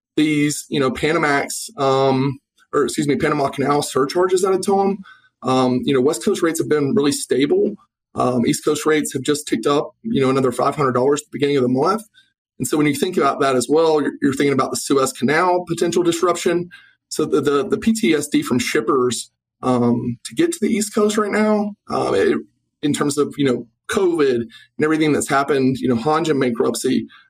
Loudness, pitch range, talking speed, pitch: -19 LUFS, 135-195 Hz, 205 wpm, 150 Hz